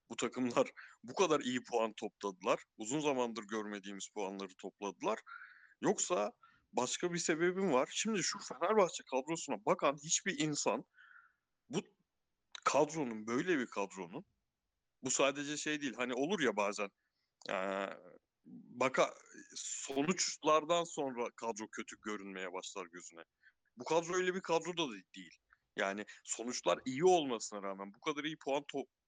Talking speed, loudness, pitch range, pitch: 130 wpm, -37 LUFS, 105-165 Hz, 130 Hz